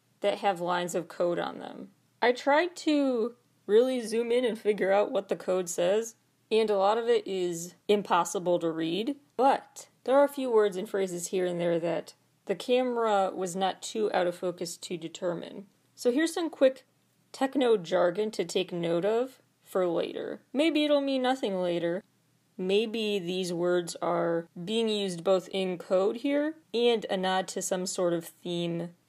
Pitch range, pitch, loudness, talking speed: 175-230 Hz, 195 Hz, -29 LUFS, 175 wpm